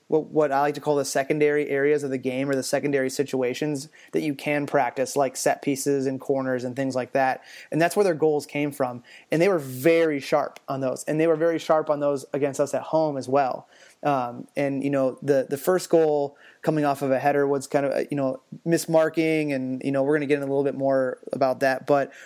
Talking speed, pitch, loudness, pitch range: 240 wpm, 140 Hz, -24 LUFS, 135-150 Hz